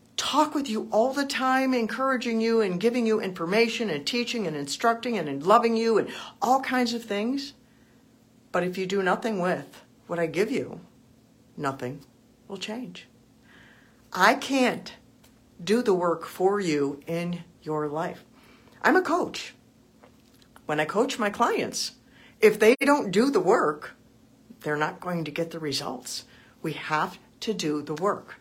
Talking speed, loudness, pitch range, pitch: 155 wpm, -26 LUFS, 160-235 Hz, 205 Hz